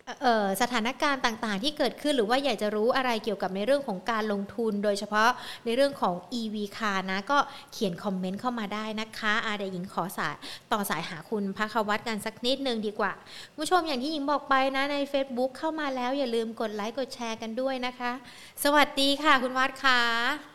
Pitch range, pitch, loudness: 210-270 Hz, 235 Hz, -28 LUFS